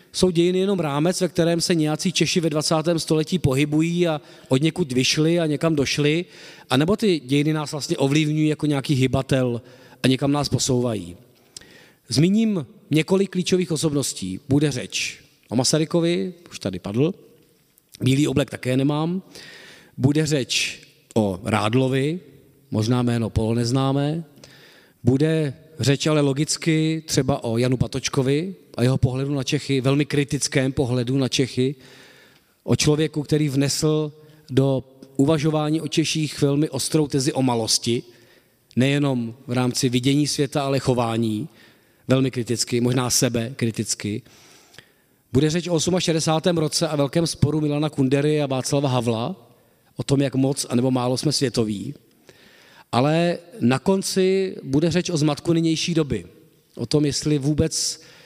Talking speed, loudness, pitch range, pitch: 140 wpm, -22 LUFS, 130-160 Hz, 145 Hz